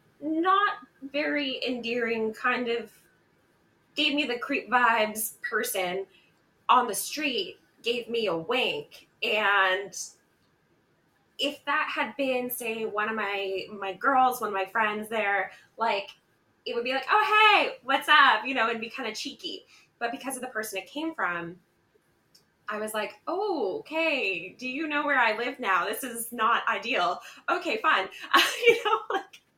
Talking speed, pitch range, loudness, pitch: 160 wpm, 215-300 Hz, -26 LUFS, 250 Hz